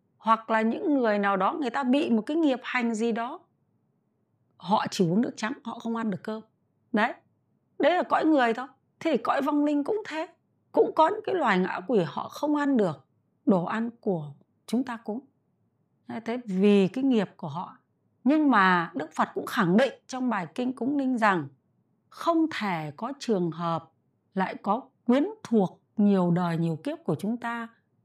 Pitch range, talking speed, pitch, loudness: 195-275 Hz, 195 wpm, 230 Hz, -27 LUFS